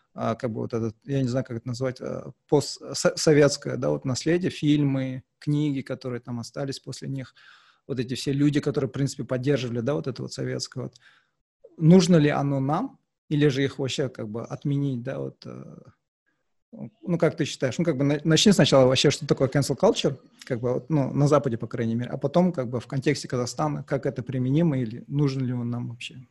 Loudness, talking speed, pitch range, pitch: -25 LUFS, 200 wpm, 125-150 Hz, 140 Hz